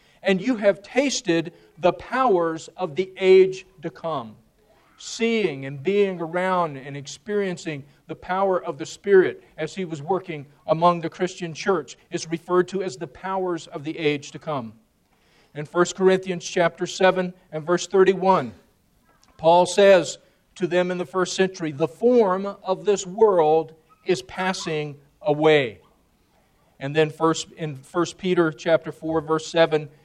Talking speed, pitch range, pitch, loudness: 150 wpm, 160-190 Hz, 175 Hz, -22 LUFS